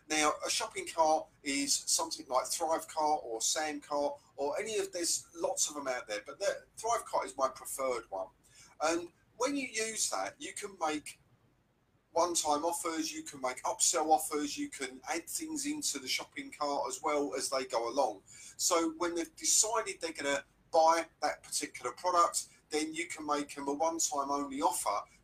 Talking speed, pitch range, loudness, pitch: 190 wpm, 145-175 Hz, -33 LUFS, 155 Hz